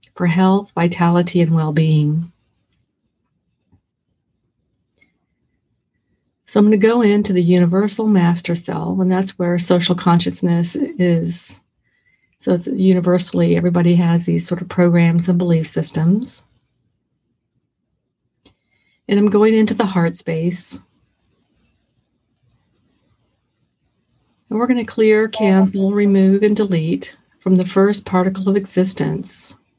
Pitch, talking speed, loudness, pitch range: 180 Hz, 115 wpm, -16 LUFS, 170-200 Hz